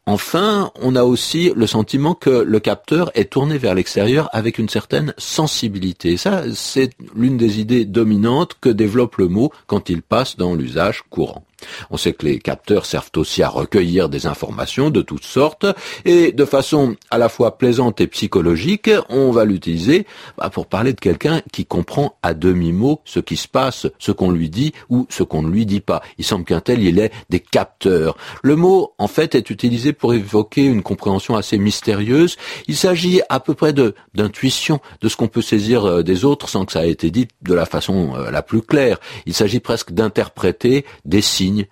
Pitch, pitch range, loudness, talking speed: 115 Hz, 105-140 Hz, -17 LUFS, 195 wpm